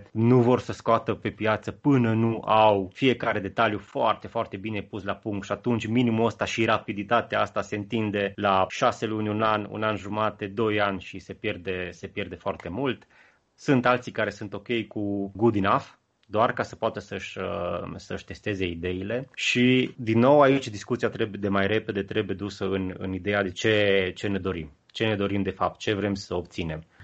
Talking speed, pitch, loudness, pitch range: 195 wpm, 105 Hz, -26 LUFS, 100-115 Hz